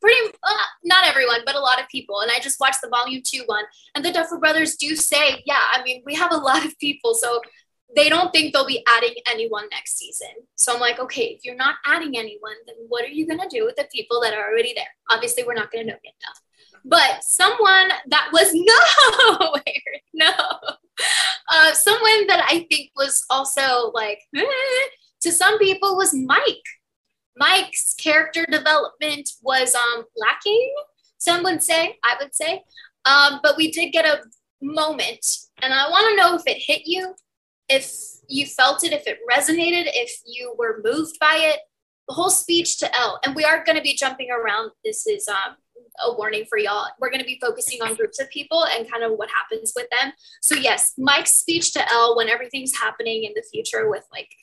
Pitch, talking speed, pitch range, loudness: 310 Hz, 200 wpm, 260-380 Hz, -18 LUFS